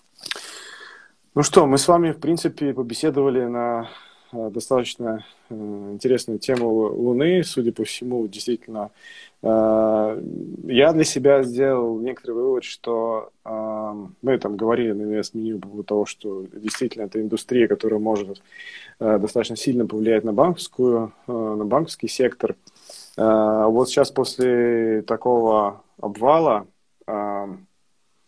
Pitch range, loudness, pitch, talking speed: 110-130 Hz, -21 LUFS, 115 Hz, 125 wpm